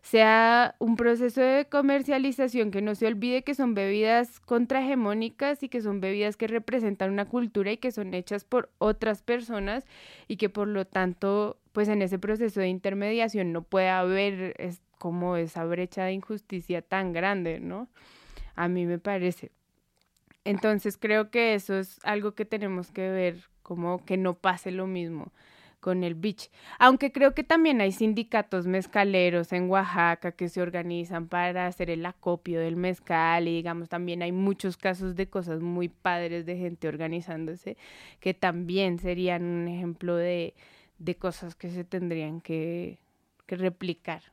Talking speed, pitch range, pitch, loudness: 160 wpm, 175-215 Hz, 190 Hz, -28 LUFS